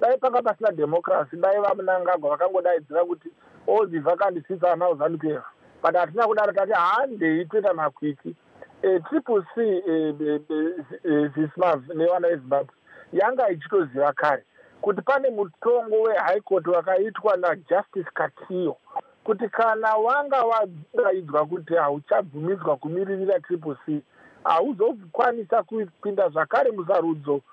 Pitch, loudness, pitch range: 185 Hz, -24 LUFS, 165-220 Hz